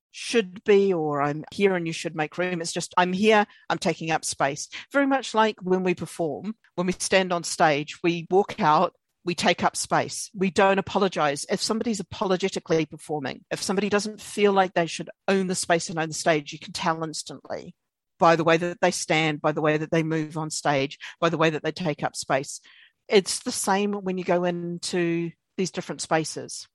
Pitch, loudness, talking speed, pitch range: 175 Hz, -25 LUFS, 210 wpm, 160-195 Hz